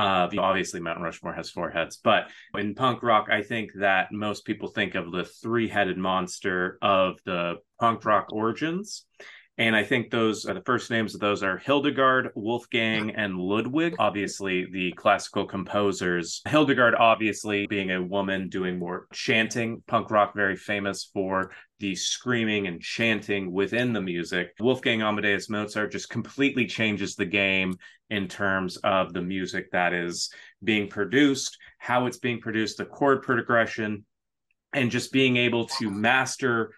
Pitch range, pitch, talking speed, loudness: 95-115 Hz, 105 Hz, 155 wpm, -26 LUFS